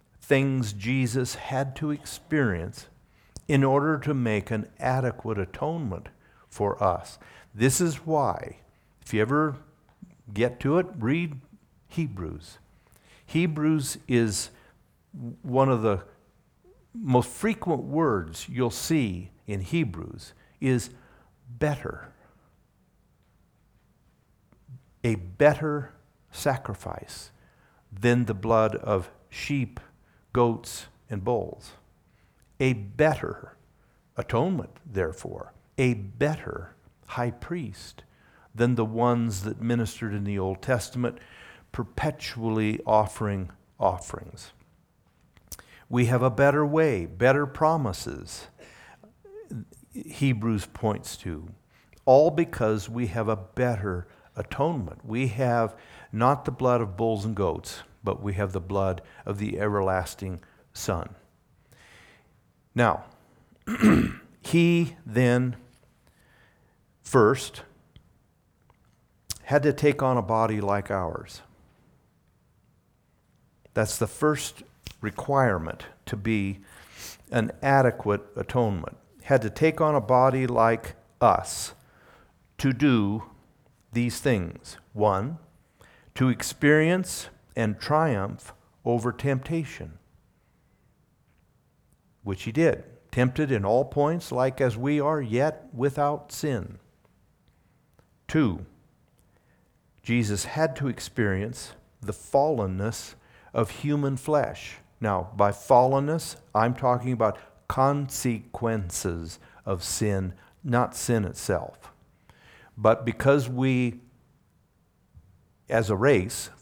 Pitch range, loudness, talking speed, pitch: 105-140 Hz, -26 LUFS, 95 wpm, 120 Hz